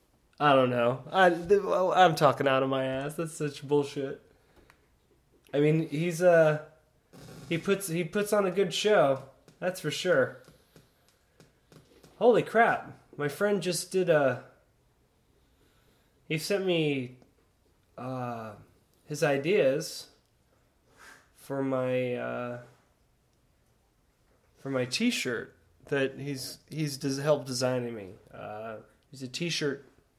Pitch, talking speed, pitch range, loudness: 145 Hz, 115 wpm, 130-170 Hz, -28 LUFS